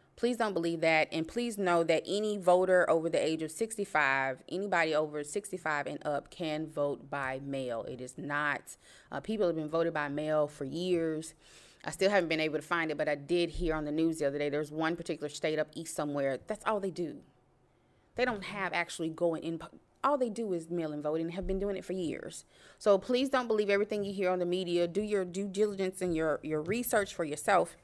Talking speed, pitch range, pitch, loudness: 225 wpm, 150-195 Hz, 165 Hz, -32 LUFS